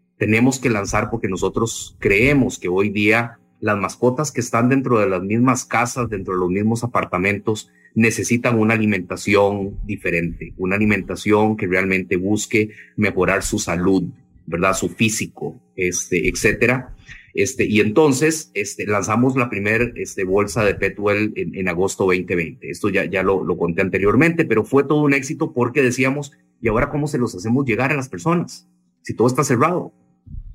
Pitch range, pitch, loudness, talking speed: 95-120 Hz, 105 Hz, -19 LUFS, 165 wpm